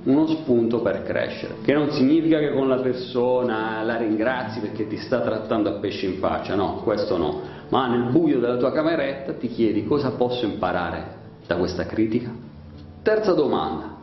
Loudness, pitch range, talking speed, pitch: -23 LUFS, 105-135 Hz, 170 wpm, 120 Hz